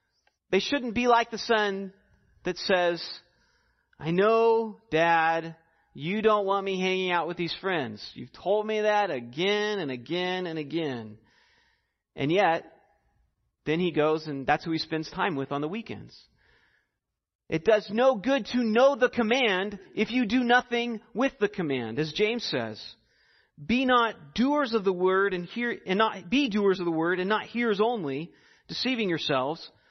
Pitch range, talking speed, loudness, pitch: 165-230 Hz, 165 wpm, -27 LUFS, 195 Hz